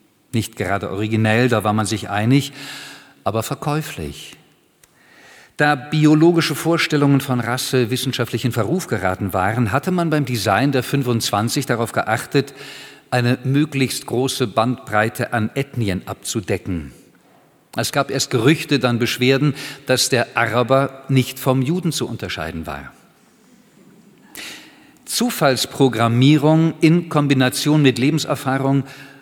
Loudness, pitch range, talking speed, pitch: -18 LUFS, 115-150 Hz, 115 wpm, 135 Hz